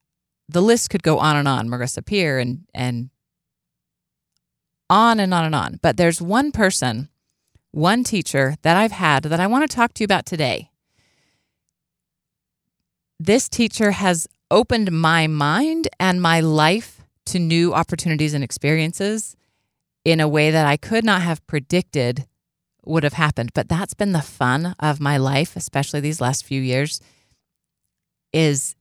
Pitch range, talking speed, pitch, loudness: 140-185 Hz, 155 wpm, 160 Hz, -19 LUFS